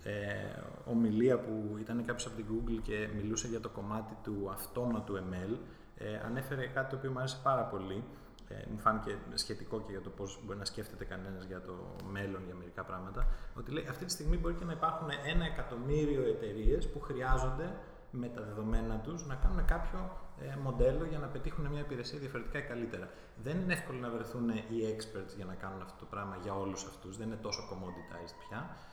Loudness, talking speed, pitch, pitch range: -38 LUFS, 195 wpm, 115 Hz, 100-130 Hz